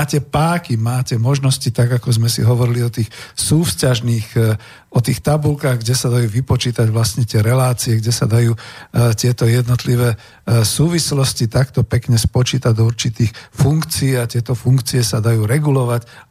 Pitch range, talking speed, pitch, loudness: 115-130 Hz, 145 wpm, 125 Hz, -16 LUFS